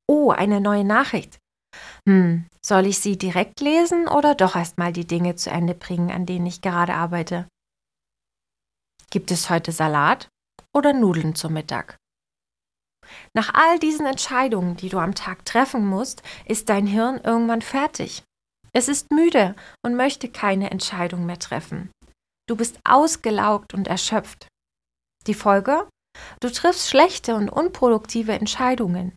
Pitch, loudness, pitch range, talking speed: 205 Hz, -21 LUFS, 180-255 Hz, 140 wpm